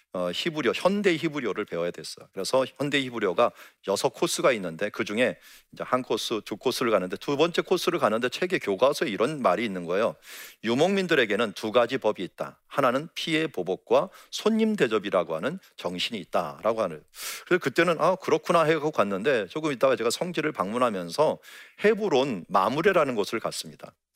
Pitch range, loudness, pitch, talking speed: 120-185 Hz, -26 LUFS, 155 Hz, 395 characters per minute